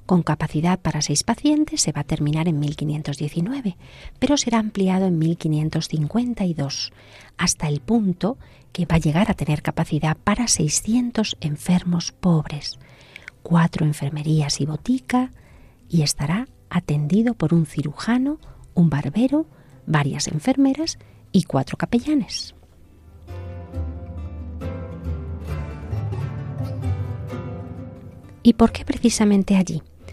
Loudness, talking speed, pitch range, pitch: -22 LUFS, 105 wpm, 130-195 Hz, 155 Hz